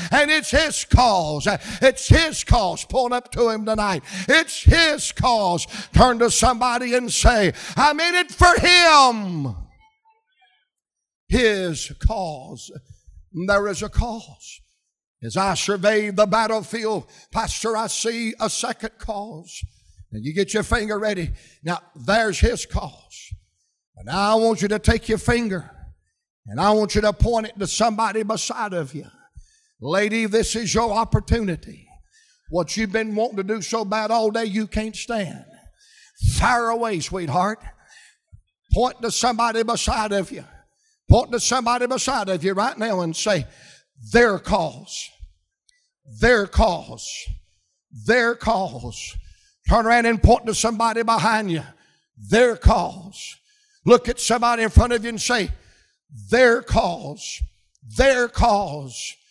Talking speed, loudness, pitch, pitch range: 140 wpm, -20 LUFS, 220 Hz, 195-240 Hz